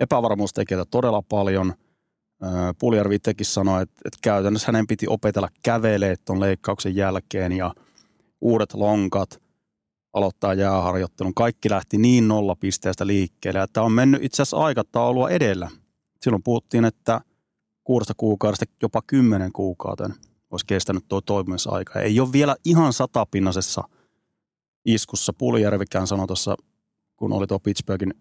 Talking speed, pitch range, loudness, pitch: 120 wpm, 95-115 Hz, -22 LUFS, 100 Hz